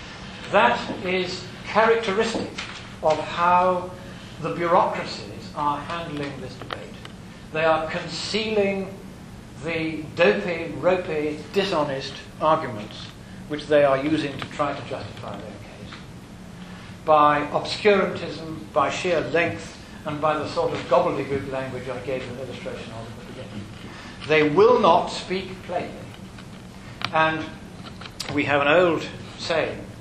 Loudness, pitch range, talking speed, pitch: -23 LUFS, 130-175 Hz, 120 wpm, 155 Hz